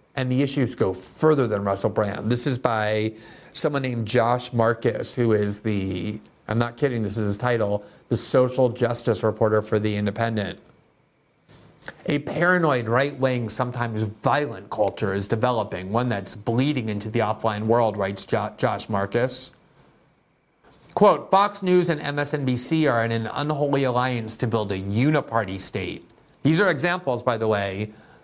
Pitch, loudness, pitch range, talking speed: 115 Hz, -23 LUFS, 105-130 Hz, 155 wpm